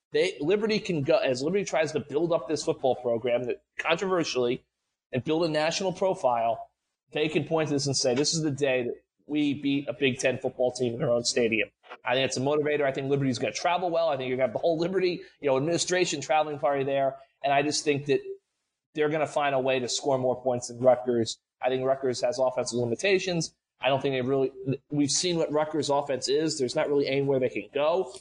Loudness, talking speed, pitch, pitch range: -27 LUFS, 235 wpm, 140 Hz, 130-160 Hz